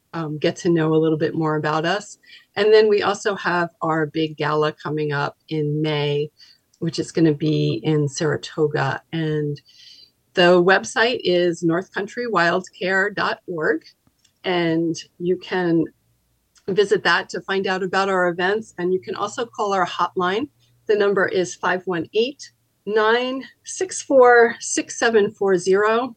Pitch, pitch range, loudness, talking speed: 180 Hz, 160-205 Hz, -20 LUFS, 135 wpm